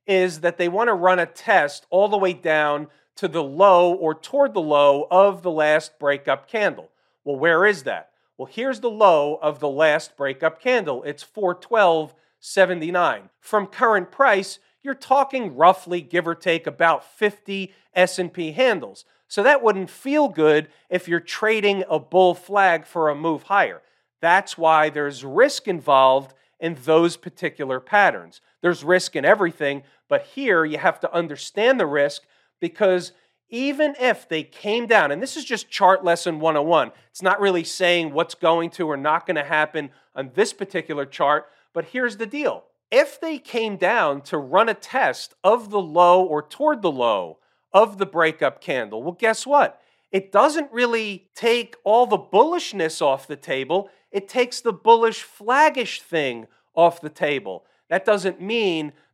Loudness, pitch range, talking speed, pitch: -20 LUFS, 155-215 Hz, 165 wpm, 180 Hz